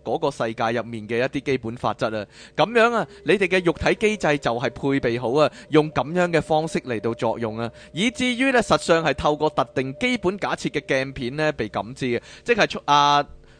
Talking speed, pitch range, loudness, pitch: 305 characters per minute, 120-170 Hz, -22 LUFS, 145 Hz